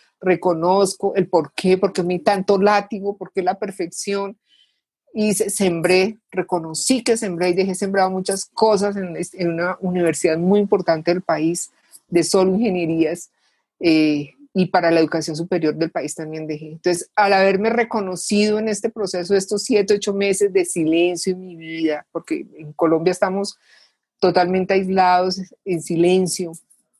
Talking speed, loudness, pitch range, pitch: 145 wpm, -19 LUFS, 170-200 Hz, 185 Hz